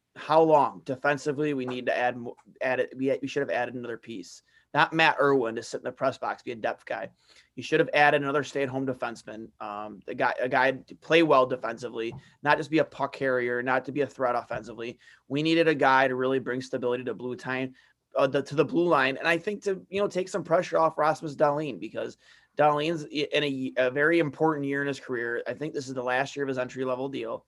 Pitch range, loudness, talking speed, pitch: 125-150 Hz, -27 LUFS, 235 wpm, 135 Hz